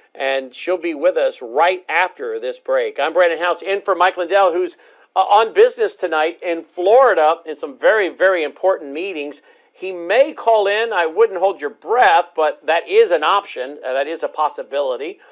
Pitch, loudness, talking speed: 200 Hz, -17 LUFS, 180 wpm